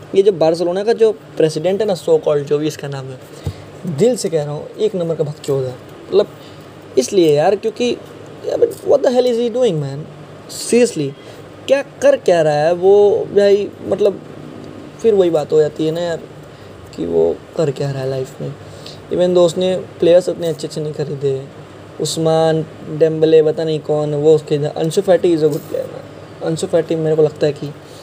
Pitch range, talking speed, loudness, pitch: 150-195 Hz, 185 wpm, -16 LUFS, 160 Hz